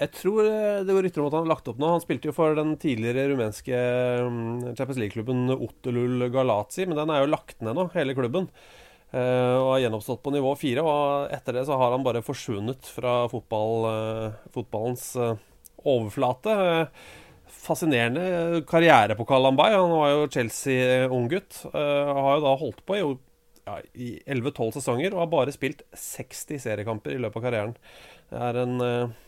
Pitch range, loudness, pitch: 120-150 Hz, -25 LUFS, 130 Hz